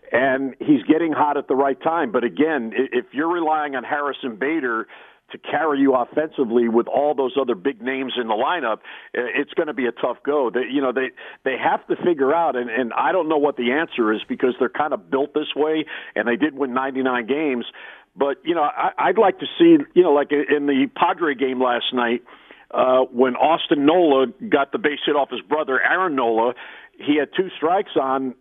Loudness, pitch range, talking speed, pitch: -20 LUFS, 130-150 Hz, 215 wpm, 140 Hz